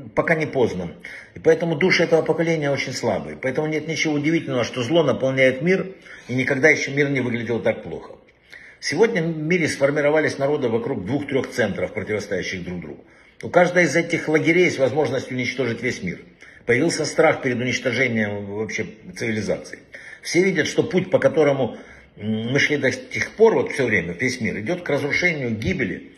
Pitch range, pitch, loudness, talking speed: 130-165 Hz, 150 Hz, -21 LUFS, 165 wpm